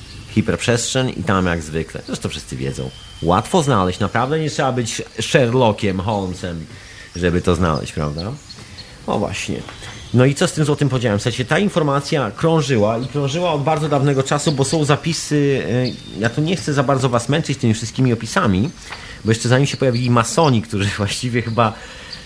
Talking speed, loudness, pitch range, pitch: 180 wpm, -18 LUFS, 100-140 Hz, 120 Hz